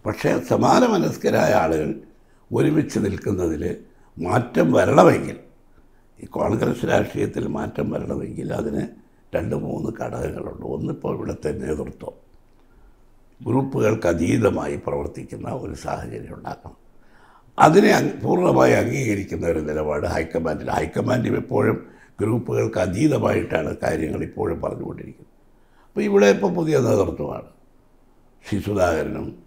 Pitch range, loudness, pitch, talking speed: 85-125 Hz, -21 LUFS, 100 Hz, 90 wpm